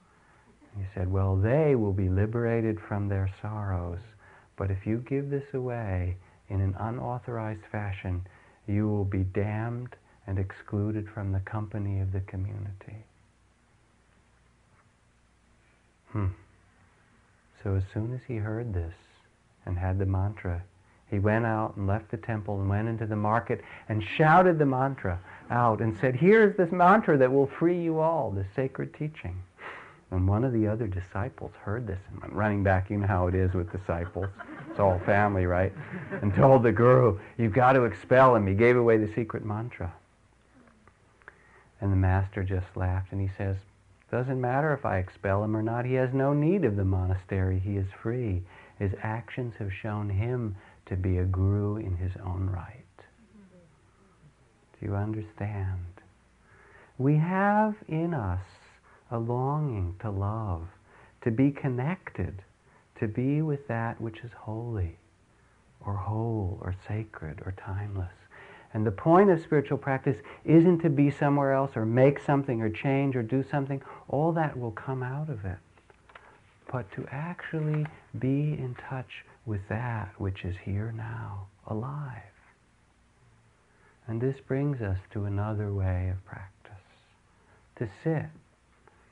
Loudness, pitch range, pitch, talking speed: -28 LUFS, 95-130 Hz, 110 Hz, 155 wpm